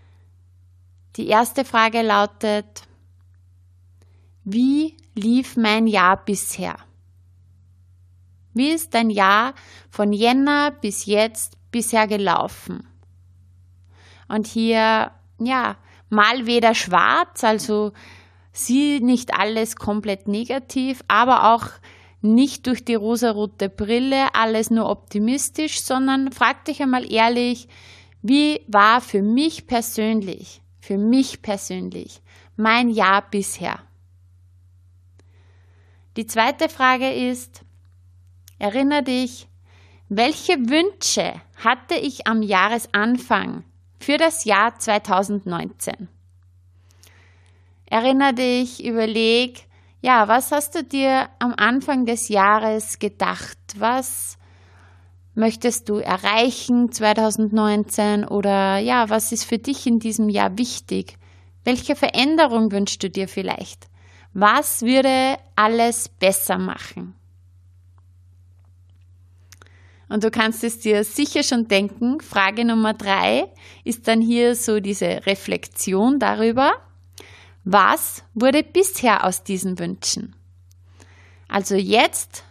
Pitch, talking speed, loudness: 210 Hz, 100 wpm, -19 LUFS